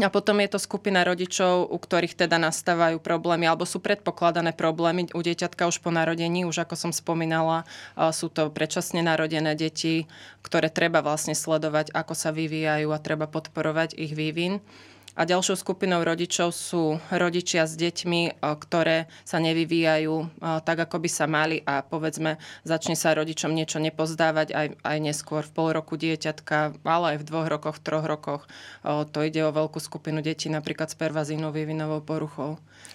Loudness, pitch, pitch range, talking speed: -26 LUFS, 160 Hz, 155-170 Hz, 165 wpm